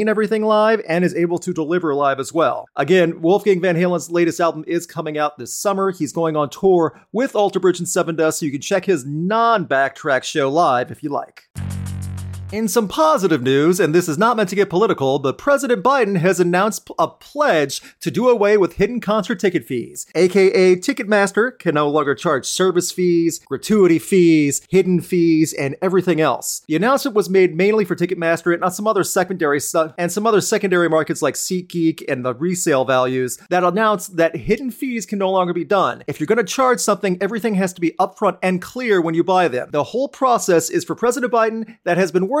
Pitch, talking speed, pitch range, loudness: 180 Hz, 205 wpm, 160-210 Hz, -18 LUFS